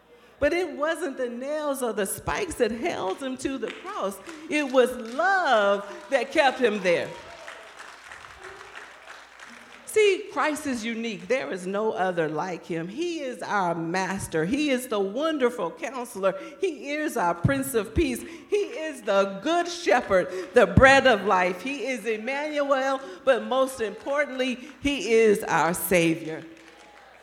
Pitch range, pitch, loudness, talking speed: 195-290 Hz, 250 Hz, -25 LUFS, 145 wpm